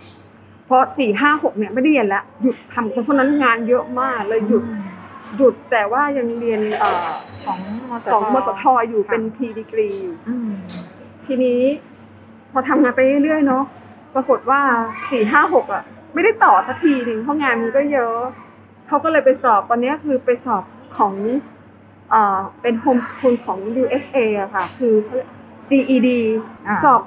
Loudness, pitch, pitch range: -18 LUFS, 250 Hz, 225-275 Hz